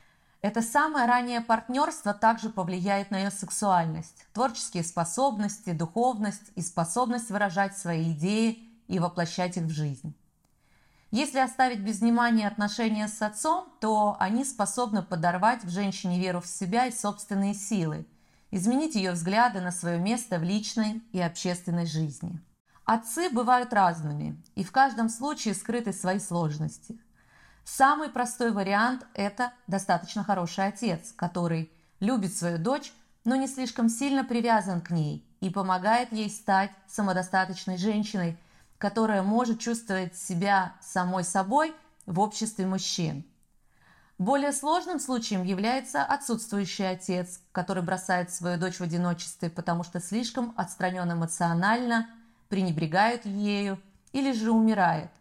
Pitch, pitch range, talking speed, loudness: 200 Hz, 180-230 Hz, 125 wpm, -28 LUFS